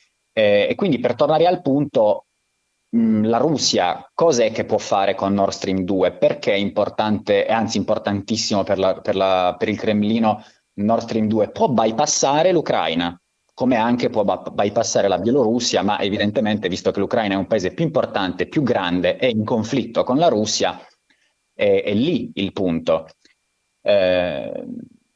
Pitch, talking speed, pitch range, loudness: 105 Hz, 160 wpm, 95-115 Hz, -19 LUFS